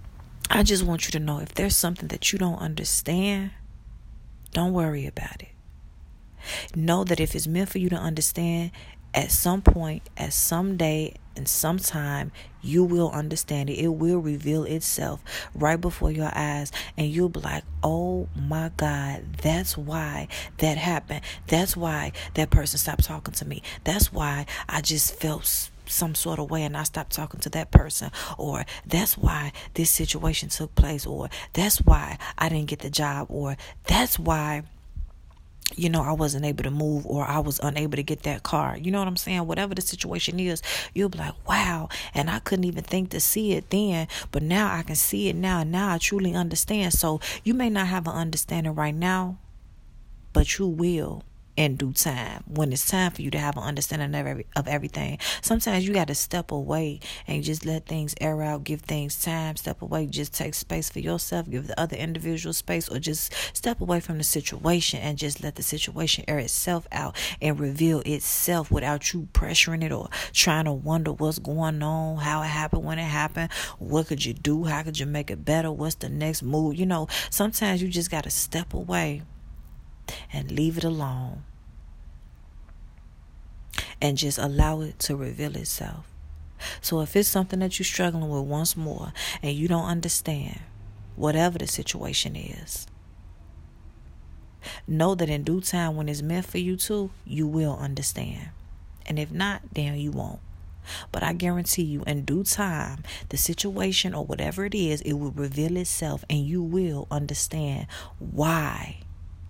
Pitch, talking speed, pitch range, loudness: 155 Hz, 180 wpm, 140-170 Hz, -26 LUFS